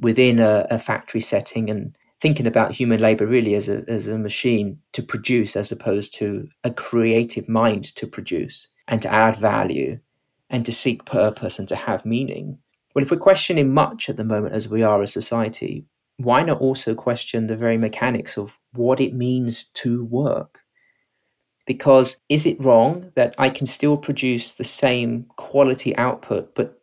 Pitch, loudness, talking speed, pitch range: 120 Hz, -20 LUFS, 175 wpm, 110-135 Hz